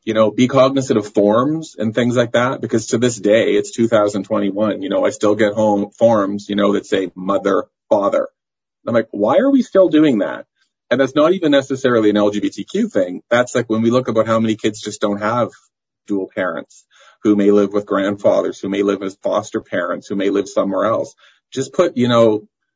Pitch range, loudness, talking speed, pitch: 105-130 Hz, -17 LUFS, 210 wpm, 110 Hz